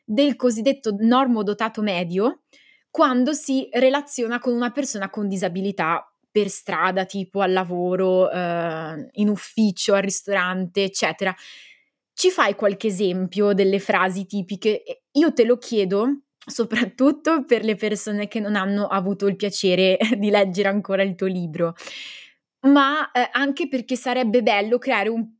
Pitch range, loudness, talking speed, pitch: 195-250 Hz, -21 LUFS, 140 wpm, 210 Hz